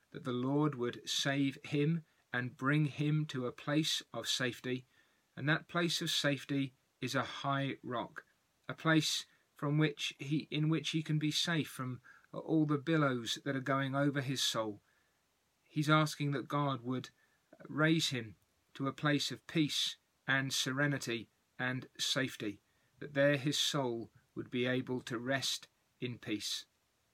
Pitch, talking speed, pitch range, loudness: 140 Hz, 155 wpm, 125-150 Hz, -35 LUFS